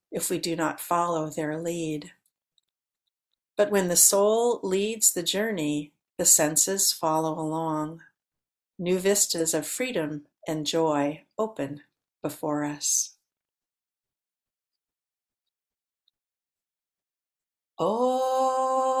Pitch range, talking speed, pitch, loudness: 155-200 Hz, 90 wpm, 170 Hz, -25 LUFS